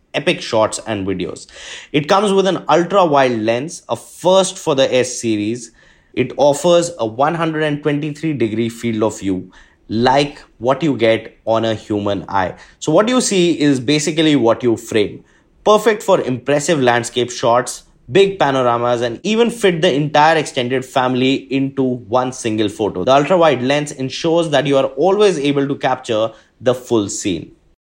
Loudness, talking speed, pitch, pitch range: -16 LUFS, 160 wpm, 135 Hz, 115-160 Hz